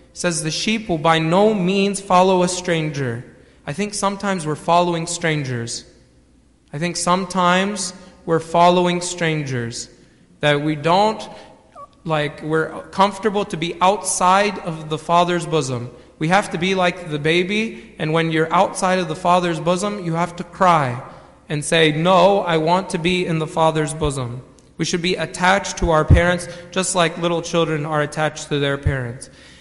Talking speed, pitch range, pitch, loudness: 165 wpm, 155-185 Hz, 175 Hz, -19 LUFS